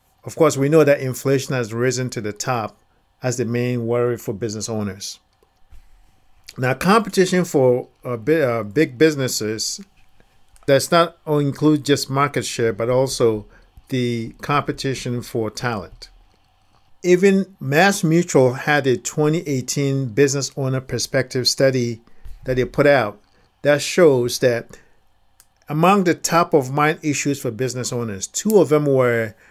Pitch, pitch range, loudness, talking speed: 130 Hz, 120-150 Hz, -19 LUFS, 135 wpm